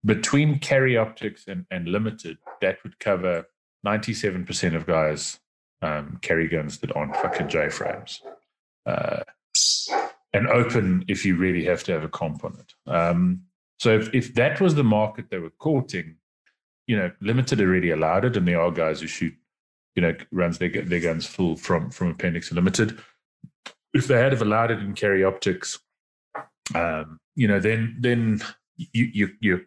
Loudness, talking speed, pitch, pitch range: -24 LUFS, 180 wpm, 105 Hz, 85-120 Hz